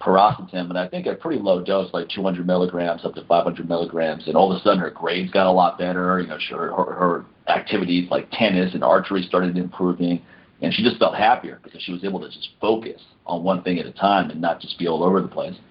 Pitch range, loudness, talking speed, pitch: 85-90 Hz, -21 LUFS, 240 wpm, 90 Hz